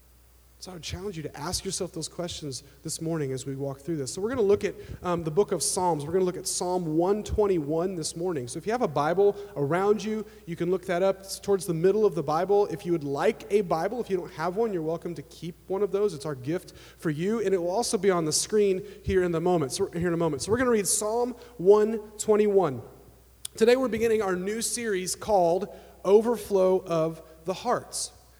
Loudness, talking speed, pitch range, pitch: -27 LUFS, 250 wpm, 160-205 Hz, 185 Hz